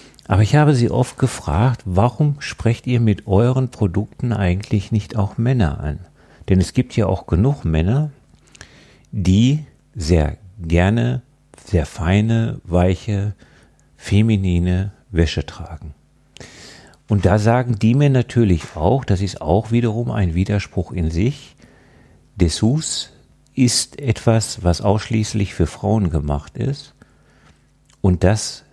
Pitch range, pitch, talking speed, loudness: 90-120 Hz, 105 Hz, 125 wpm, -19 LUFS